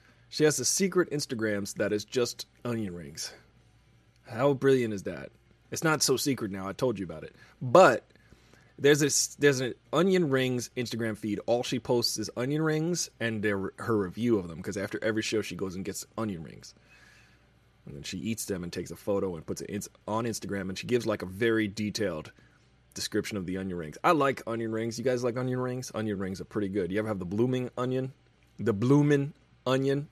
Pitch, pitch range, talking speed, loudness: 115 Hz, 100-130 Hz, 205 wpm, -29 LUFS